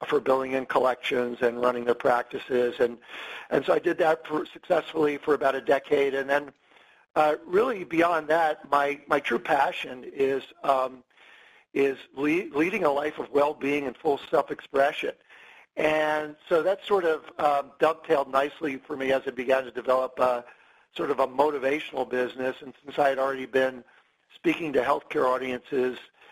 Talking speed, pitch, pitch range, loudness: 165 wpm, 140 Hz, 130-155 Hz, -26 LUFS